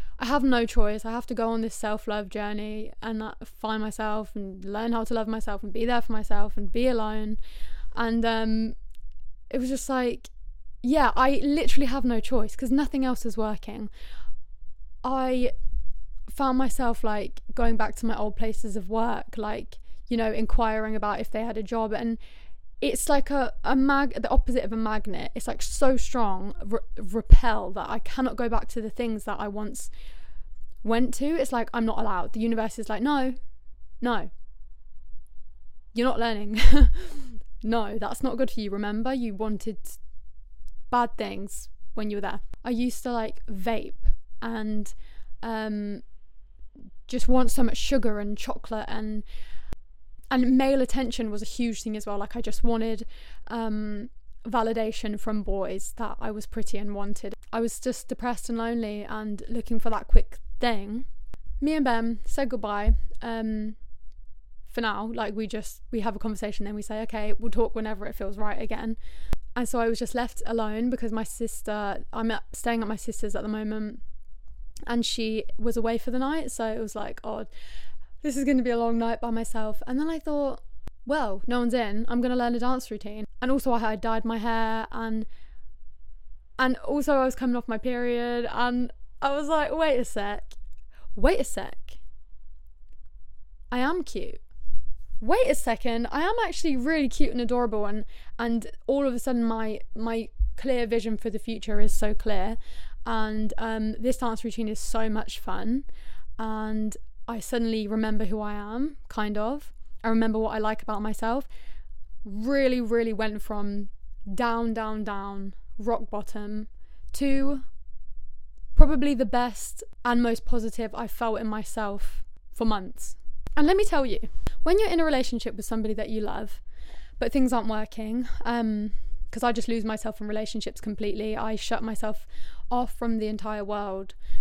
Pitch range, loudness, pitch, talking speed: 210-240 Hz, -29 LUFS, 225 Hz, 175 wpm